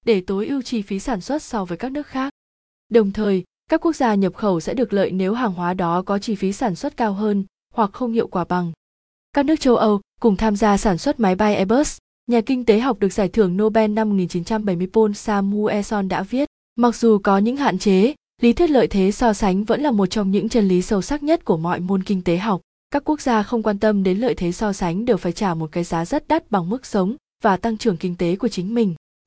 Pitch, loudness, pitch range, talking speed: 215 Hz, -20 LUFS, 195-240 Hz, 250 wpm